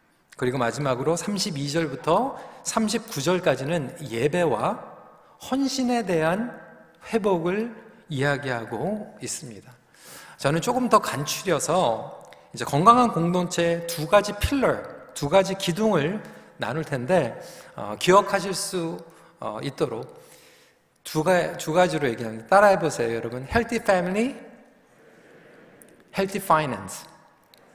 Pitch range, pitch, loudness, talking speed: 145-210 Hz, 175 Hz, -24 LUFS, 270 characters per minute